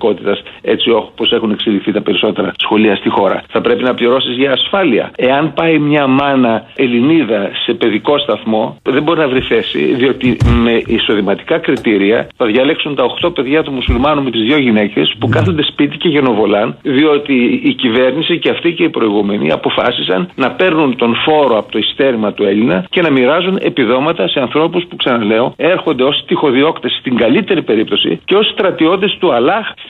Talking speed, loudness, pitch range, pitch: 170 wpm, -12 LUFS, 120-155 Hz, 135 Hz